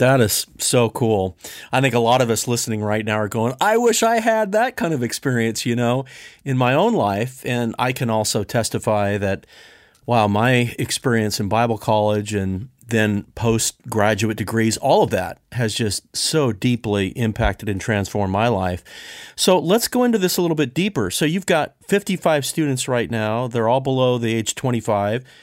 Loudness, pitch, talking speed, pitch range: -20 LUFS, 115 Hz, 185 wpm, 110-130 Hz